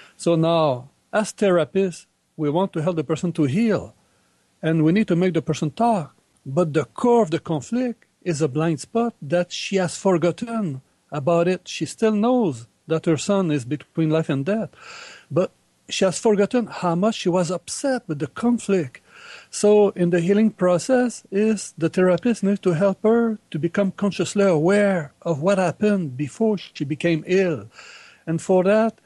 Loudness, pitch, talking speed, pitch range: -21 LUFS, 185 Hz, 175 wpm, 160-210 Hz